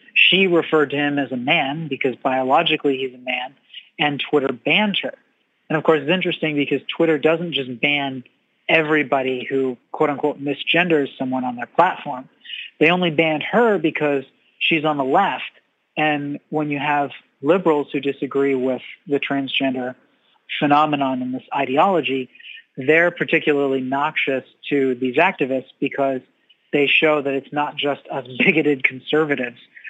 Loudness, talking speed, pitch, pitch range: -19 LUFS, 150 wpm, 145 Hz, 135-155 Hz